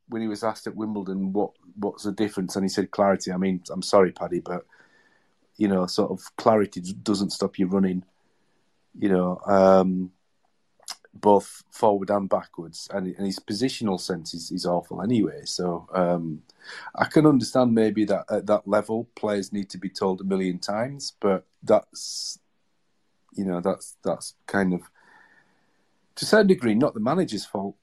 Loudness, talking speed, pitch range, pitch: -25 LUFS, 170 wpm, 95-105 Hz, 100 Hz